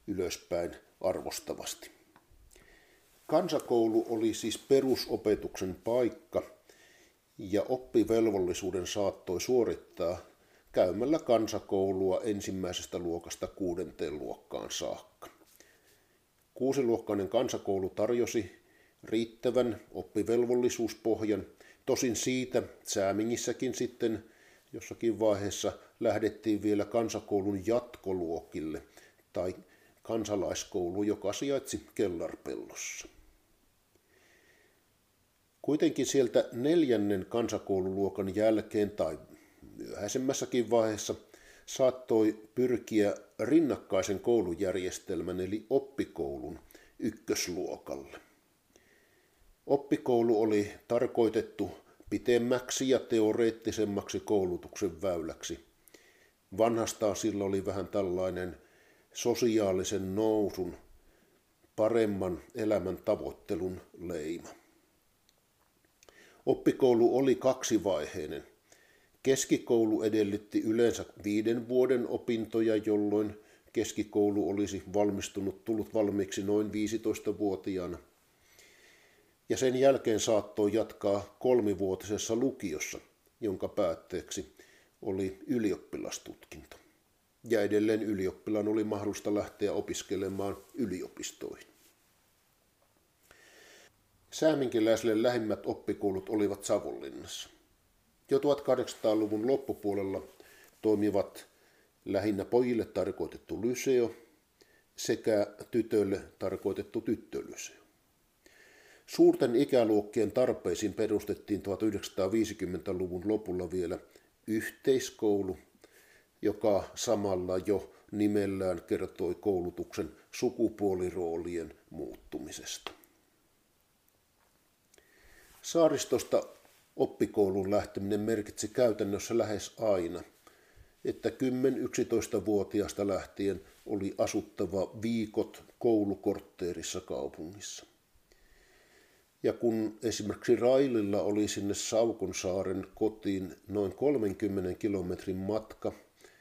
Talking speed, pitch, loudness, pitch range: 70 wpm, 110 Hz, -32 LUFS, 100-120 Hz